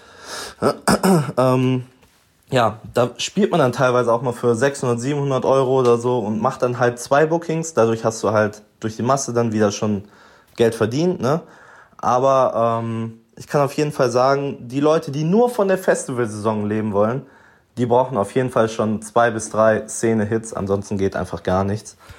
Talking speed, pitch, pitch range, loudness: 175 wpm, 120 Hz, 110-135 Hz, -19 LUFS